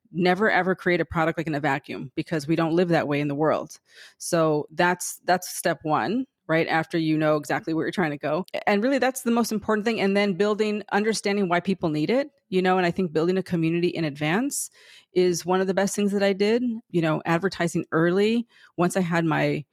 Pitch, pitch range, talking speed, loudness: 180 Hz, 160-205 Hz, 230 wpm, -24 LUFS